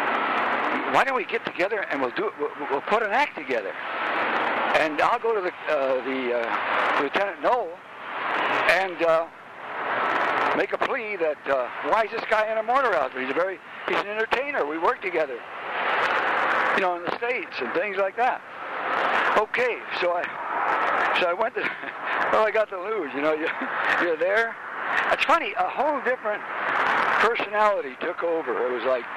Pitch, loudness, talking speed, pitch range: 205 Hz, -24 LUFS, 175 wpm, 155-225 Hz